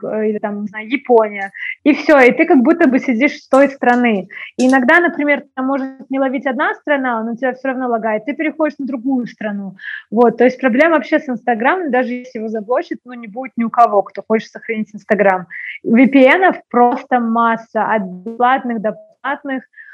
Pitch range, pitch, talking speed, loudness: 225-280 Hz, 250 Hz, 185 wpm, -15 LUFS